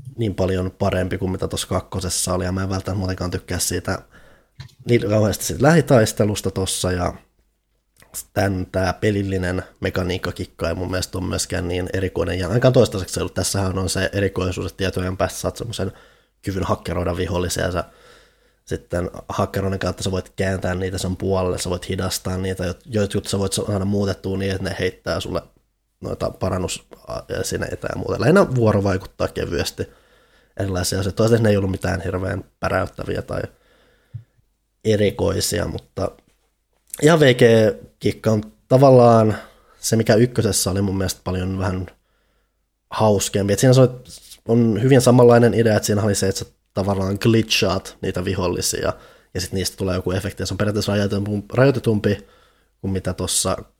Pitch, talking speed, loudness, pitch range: 95 Hz, 155 wpm, -20 LUFS, 95-110 Hz